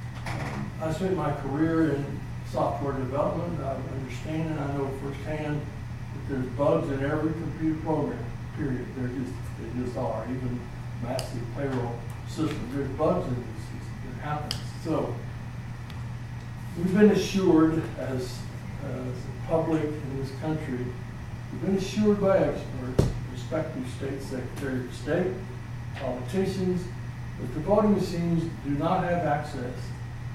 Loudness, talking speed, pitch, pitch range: -29 LUFS, 130 wpm, 130 Hz, 120-155 Hz